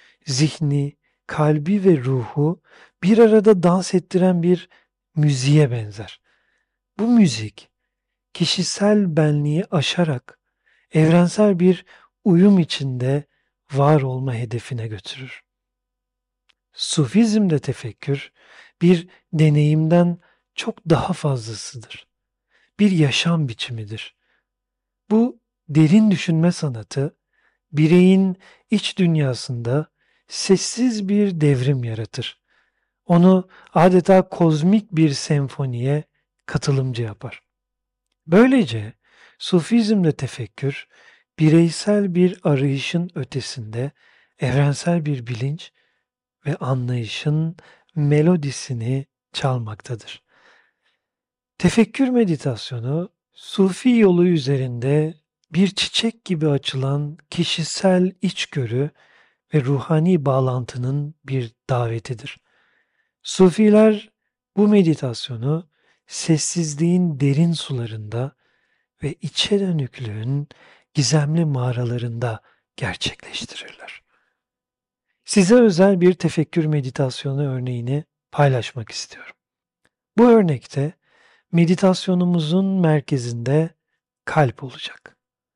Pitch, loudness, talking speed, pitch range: 155 Hz, -19 LUFS, 75 wpm, 135-180 Hz